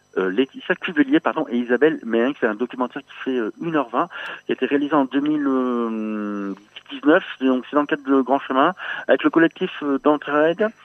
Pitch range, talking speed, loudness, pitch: 125-155 Hz, 190 wpm, -21 LUFS, 140 Hz